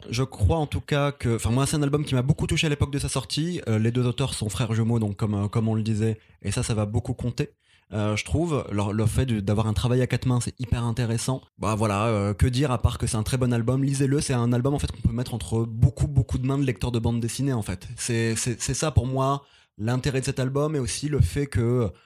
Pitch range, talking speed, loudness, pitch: 110-135 Hz, 285 wpm, -25 LUFS, 120 Hz